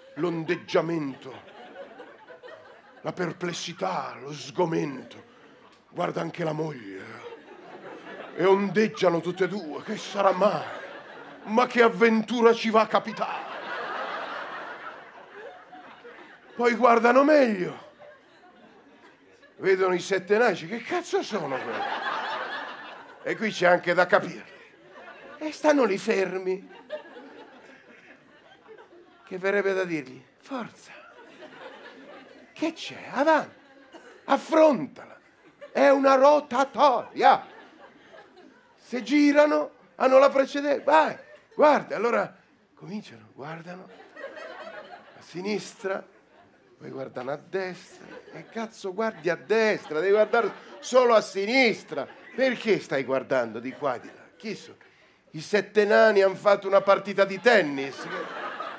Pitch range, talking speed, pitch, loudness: 180-270 Hz, 105 wpm, 210 Hz, -24 LUFS